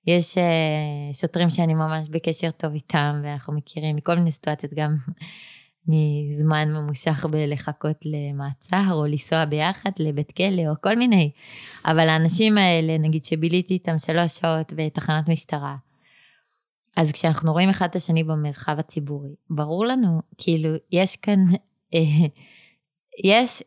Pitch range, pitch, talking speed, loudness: 150-175 Hz, 160 Hz, 125 wpm, -22 LUFS